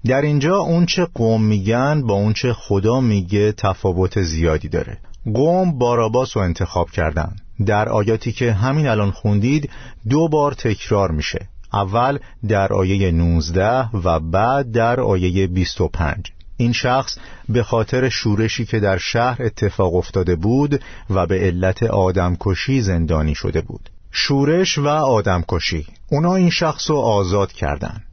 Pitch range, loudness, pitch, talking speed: 95-130 Hz, -18 LUFS, 105 Hz, 145 wpm